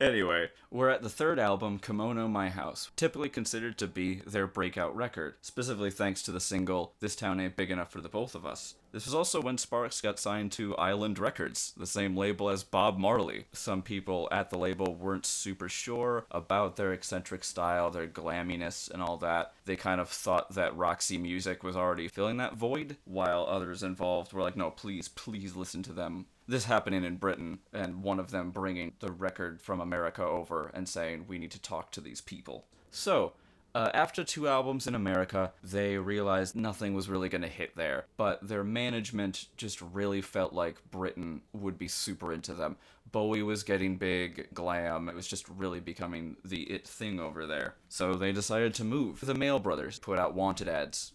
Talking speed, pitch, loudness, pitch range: 195 wpm, 95 Hz, -34 LUFS, 90-105 Hz